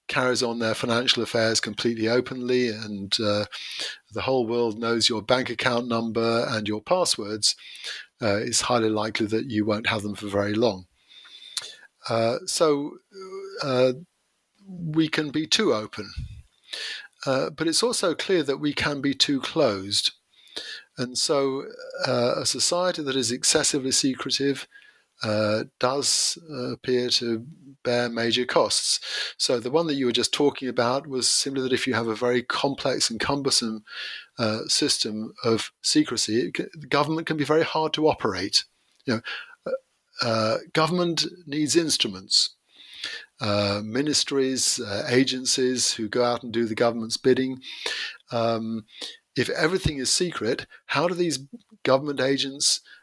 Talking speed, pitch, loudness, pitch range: 150 wpm, 125 Hz, -24 LUFS, 115-150 Hz